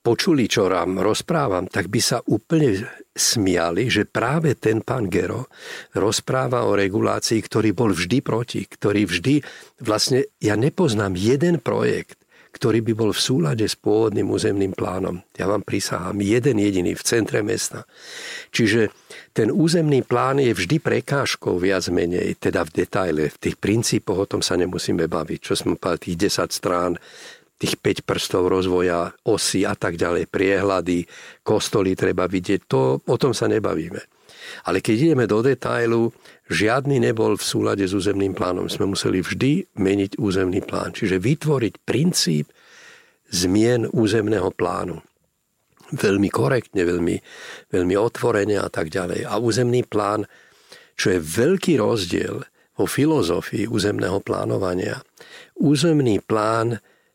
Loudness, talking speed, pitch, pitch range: -21 LUFS, 140 wpm, 110 Hz, 95-135 Hz